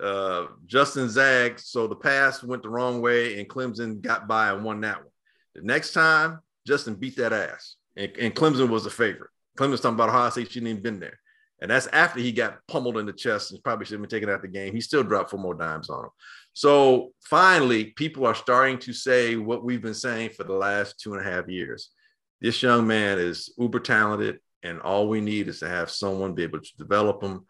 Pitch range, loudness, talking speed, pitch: 100-125 Hz, -24 LUFS, 230 wpm, 115 Hz